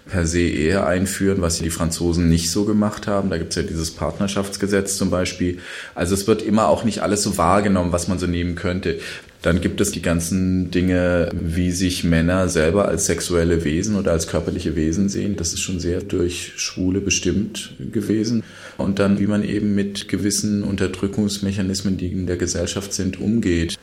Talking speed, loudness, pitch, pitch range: 185 wpm, -20 LUFS, 95 Hz, 85-100 Hz